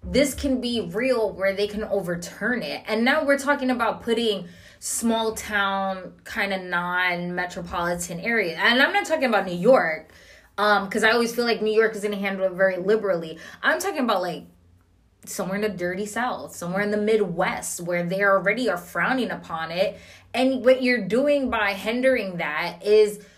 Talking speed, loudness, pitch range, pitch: 180 wpm, -23 LUFS, 185-235 Hz, 205 Hz